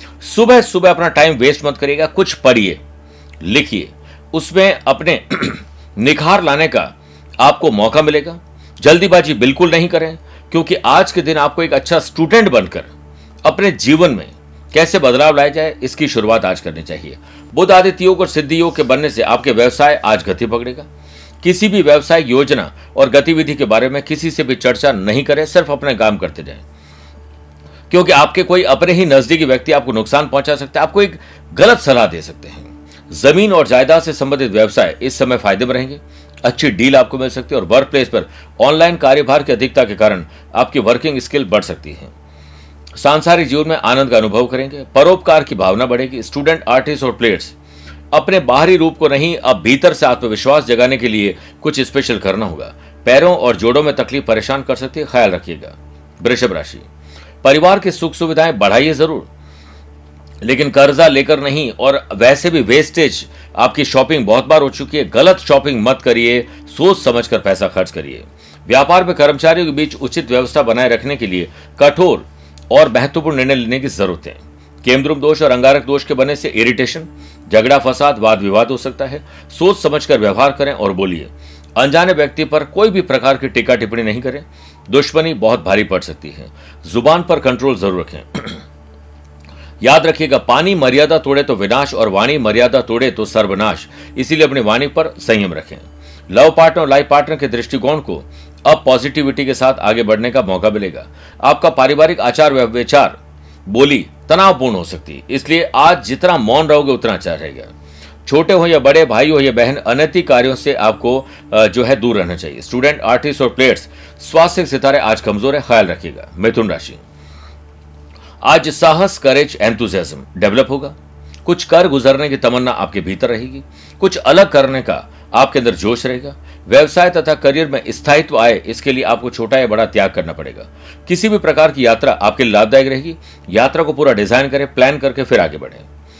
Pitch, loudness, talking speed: 130 Hz, -12 LUFS, 180 wpm